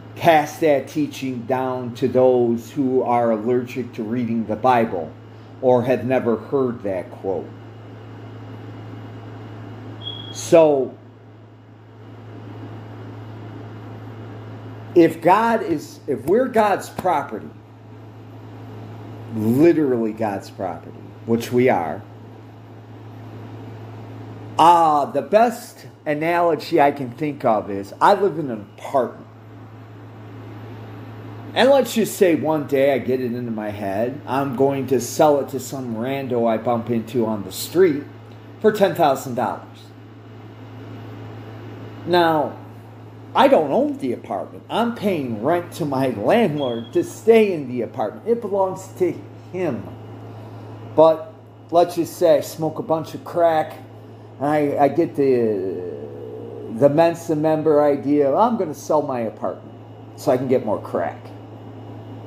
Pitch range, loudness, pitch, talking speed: 110-145 Hz, -20 LUFS, 115 Hz, 125 wpm